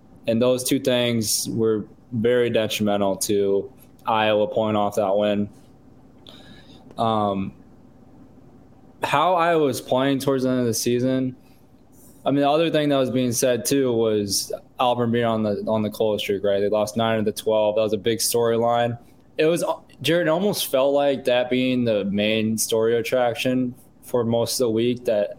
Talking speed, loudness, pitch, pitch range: 175 wpm, -22 LUFS, 115 Hz, 110-130 Hz